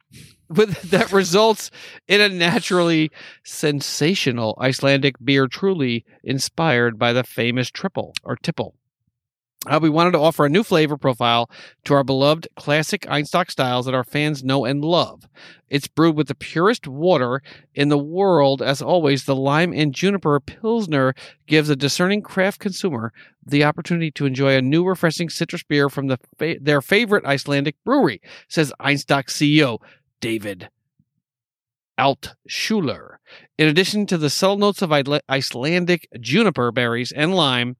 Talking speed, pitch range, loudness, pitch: 150 wpm, 135-175 Hz, -19 LUFS, 145 Hz